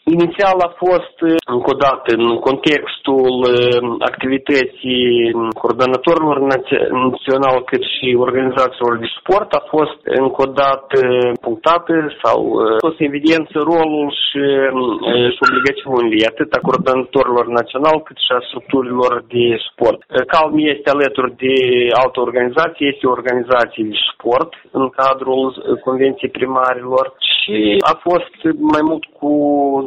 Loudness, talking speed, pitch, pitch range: -15 LUFS, 115 wpm, 130 Hz, 125-150 Hz